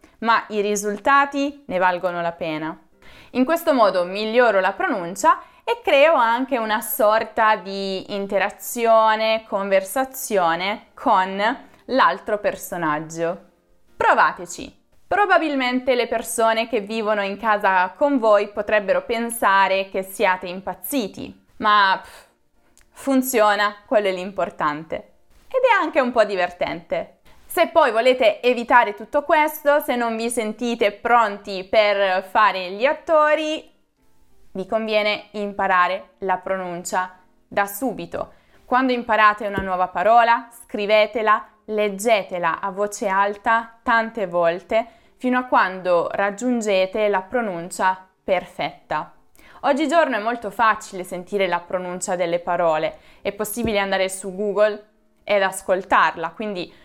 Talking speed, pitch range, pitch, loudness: 115 wpm, 190-240 Hz, 210 Hz, -20 LUFS